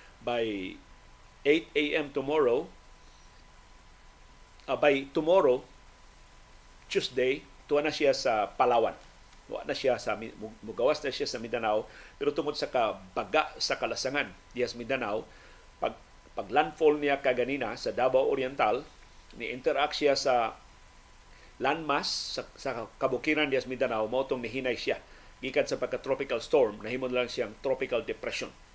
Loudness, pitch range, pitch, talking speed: -30 LUFS, 90-145 Hz, 125 Hz, 125 wpm